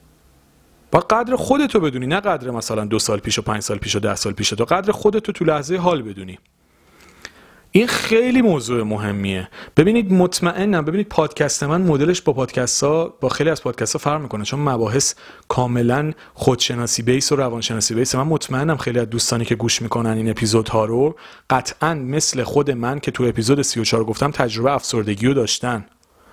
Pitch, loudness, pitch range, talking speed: 130 Hz, -19 LUFS, 115-155 Hz, 180 wpm